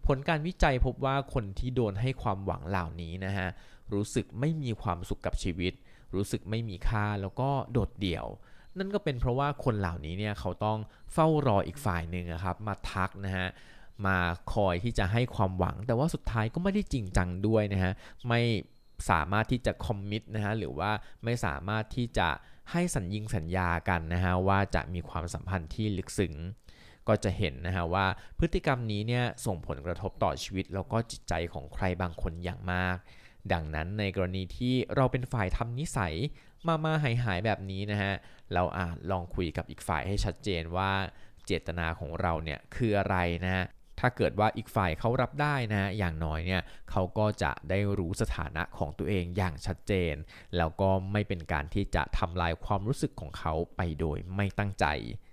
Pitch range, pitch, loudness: 90-115 Hz, 100 Hz, -32 LUFS